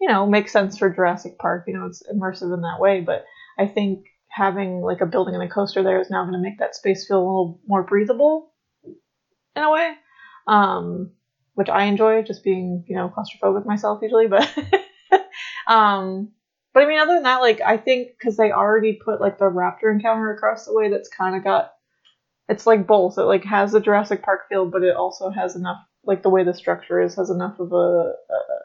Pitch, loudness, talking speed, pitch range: 200 Hz, -20 LUFS, 215 wpm, 185-225 Hz